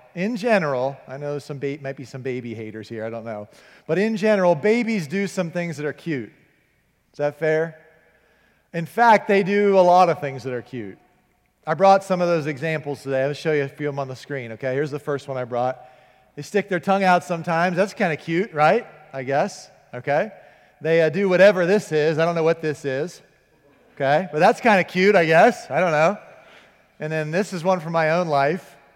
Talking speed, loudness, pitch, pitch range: 225 wpm, -21 LUFS, 155 Hz, 140-185 Hz